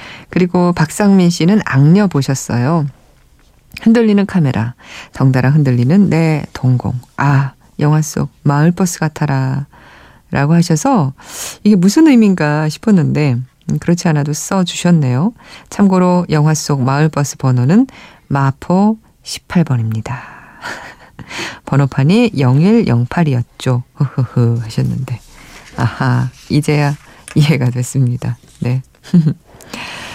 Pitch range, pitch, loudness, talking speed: 130-175 Hz, 150 Hz, -14 LUFS, 230 characters per minute